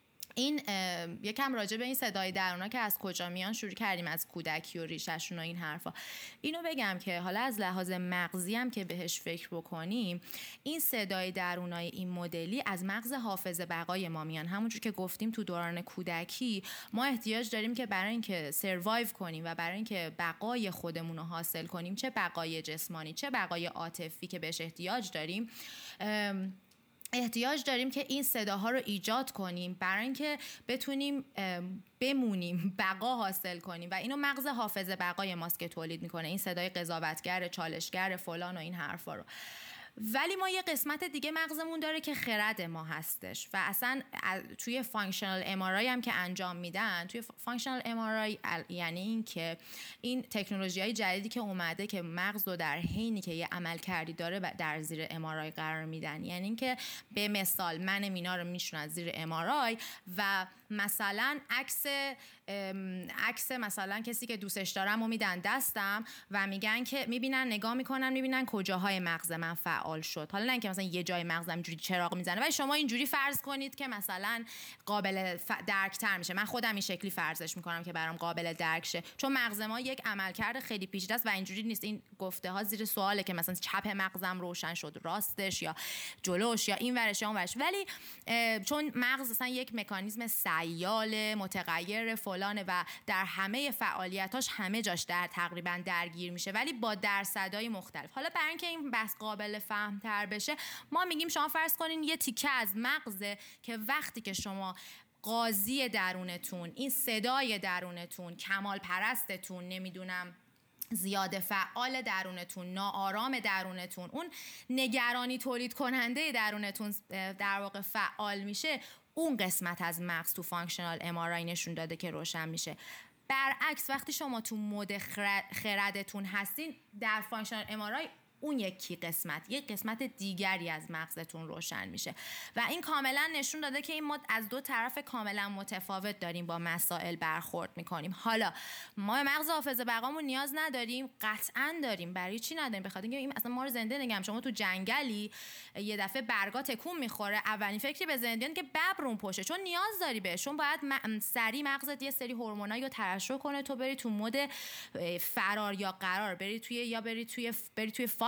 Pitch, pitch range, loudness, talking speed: 205 Hz, 180-245 Hz, -35 LUFS, 165 wpm